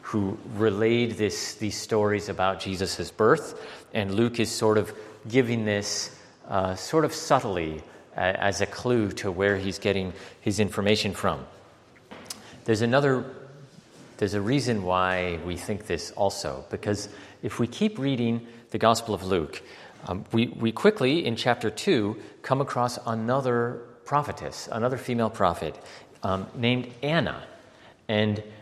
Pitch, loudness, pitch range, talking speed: 110 Hz, -26 LUFS, 100-120 Hz, 140 wpm